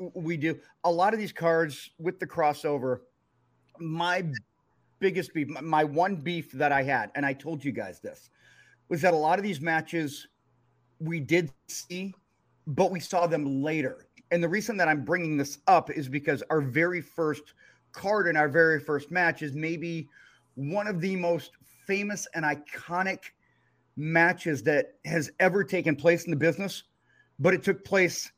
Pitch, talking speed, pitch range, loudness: 165 Hz, 170 wpm, 150-180 Hz, -28 LUFS